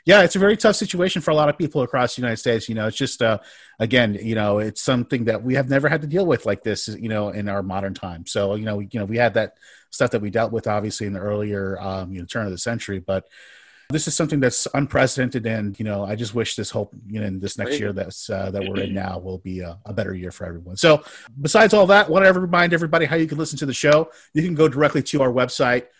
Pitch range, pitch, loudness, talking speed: 100-150 Hz, 115 Hz, -21 LUFS, 280 wpm